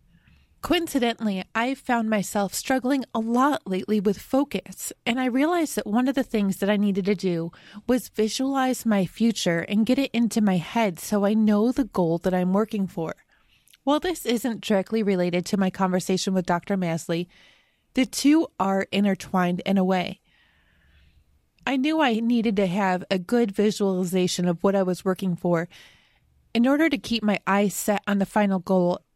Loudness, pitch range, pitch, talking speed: -24 LUFS, 185-235 Hz, 205 Hz, 175 wpm